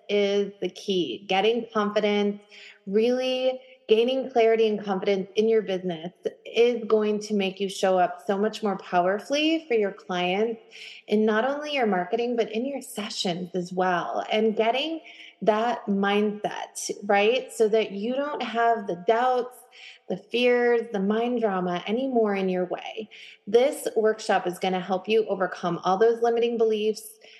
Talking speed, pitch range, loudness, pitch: 155 wpm, 195-235 Hz, -25 LUFS, 215 Hz